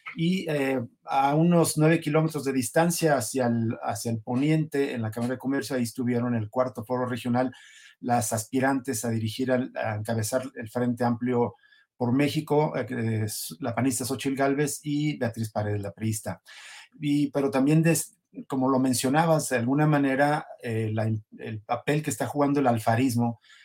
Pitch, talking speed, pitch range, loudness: 130 Hz, 165 wpm, 120-145 Hz, -26 LUFS